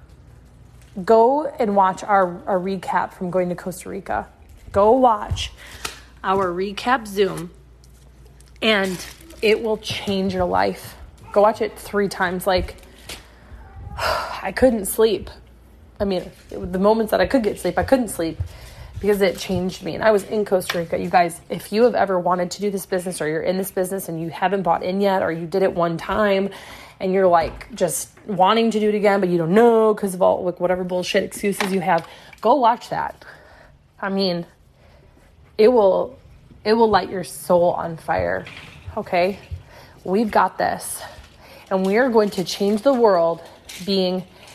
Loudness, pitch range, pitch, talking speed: -20 LUFS, 180-210 Hz, 190 Hz, 180 wpm